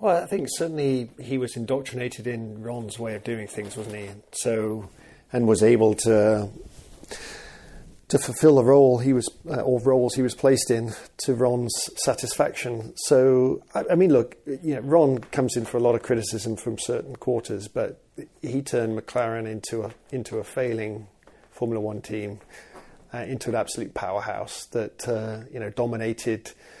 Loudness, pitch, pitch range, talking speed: -24 LUFS, 120 Hz, 110-130 Hz, 170 wpm